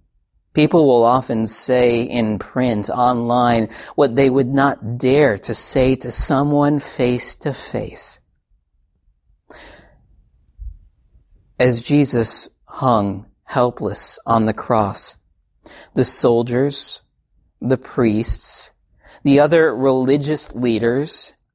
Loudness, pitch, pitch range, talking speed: -17 LUFS, 120 Hz, 105-135 Hz, 95 wpm